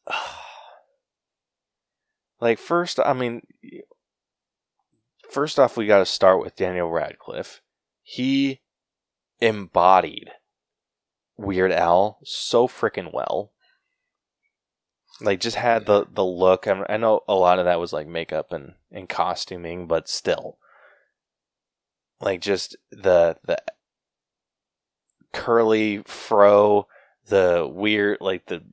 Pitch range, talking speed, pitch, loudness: 95-140 Hz, 110 wpm, 105 Hz, -21 LUFS